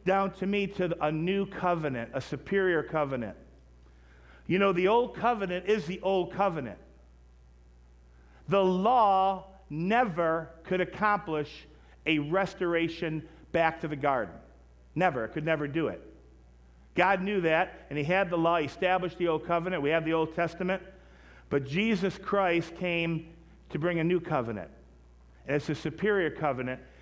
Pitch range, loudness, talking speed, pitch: 130-185 Hz, -29 LUFS, 150 wpm, 165 Hz